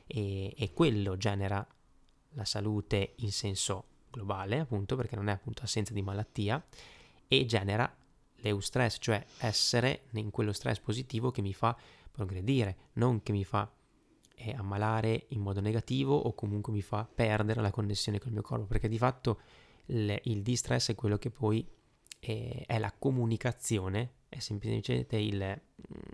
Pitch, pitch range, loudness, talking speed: 110 Hz, 105-120 Hz, -33 LUFS, 150 wpm